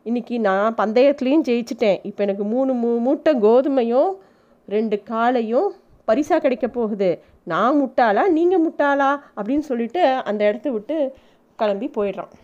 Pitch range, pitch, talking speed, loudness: 210-280 Hz, 240 Hz, 125 wpm, -20 LUFS